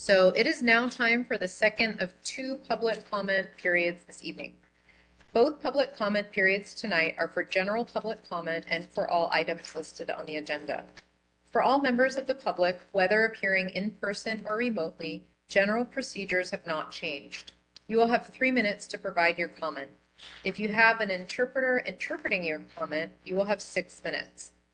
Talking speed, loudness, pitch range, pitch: 175 wpm, -29 LUFS, 165-225 Hz, 195 Hz